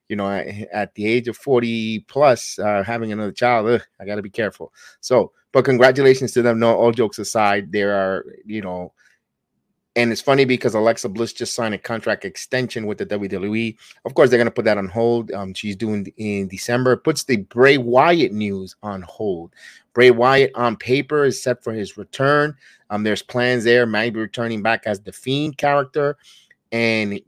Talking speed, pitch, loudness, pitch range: 185 wpm, 115 Hz, -19 LUFS, 105-125 Hz